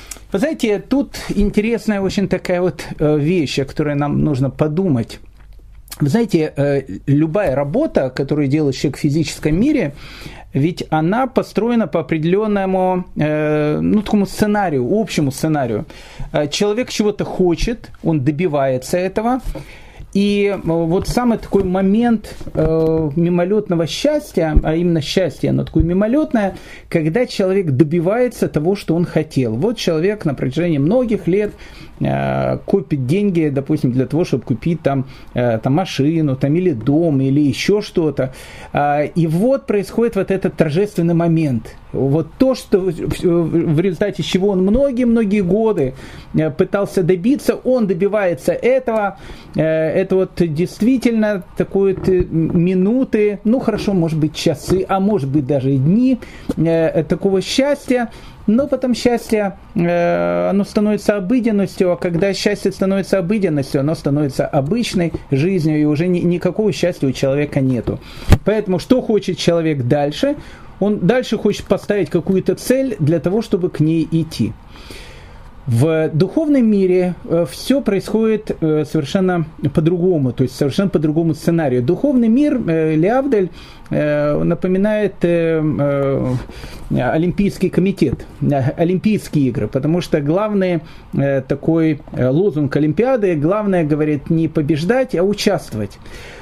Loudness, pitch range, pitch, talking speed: -17 LUFS, 155-205 Hz, 175 Hz, 120 wpm